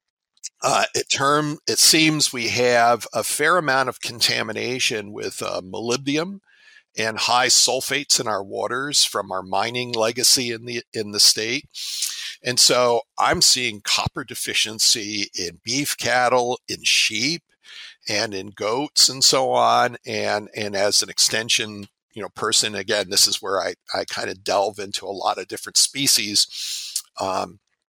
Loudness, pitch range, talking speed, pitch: -19 LUFS, 105-130 Hz, 150 wpm, 120 Hz